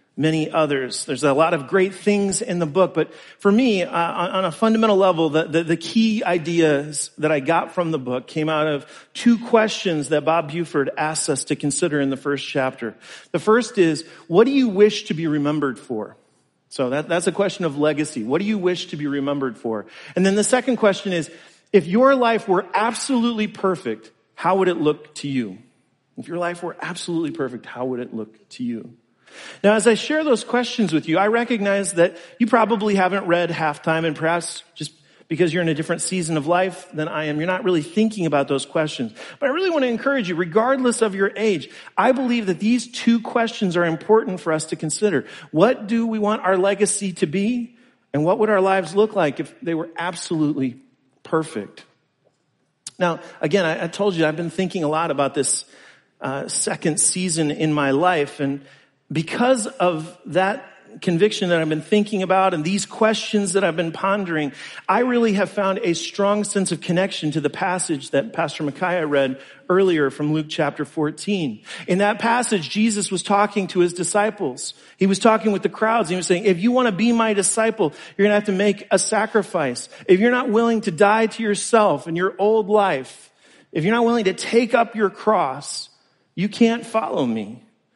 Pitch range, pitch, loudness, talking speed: 155-210 Hz, 185 Hz, -20 LUFS, 205 wpm